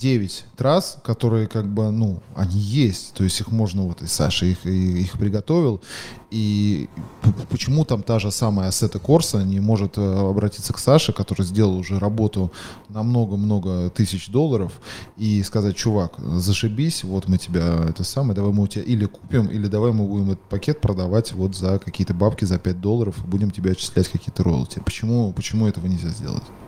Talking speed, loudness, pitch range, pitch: 180 wpm, -21 LUFS, 95-115 Hz, 105 Hz